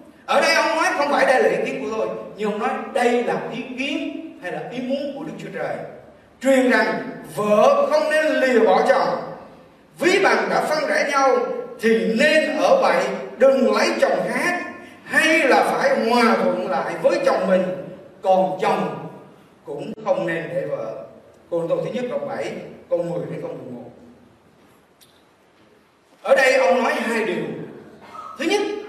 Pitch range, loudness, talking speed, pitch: 240-310 Hz, -19 LUFS, 175 wpm, 270 Hz